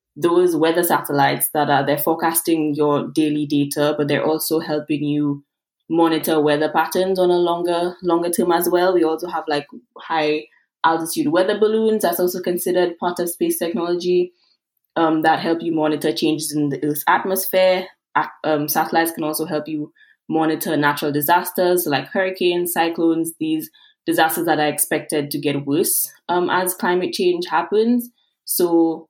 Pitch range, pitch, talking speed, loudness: 150-180 Hz, 165 Hz, 155 wpm, -19 LUFS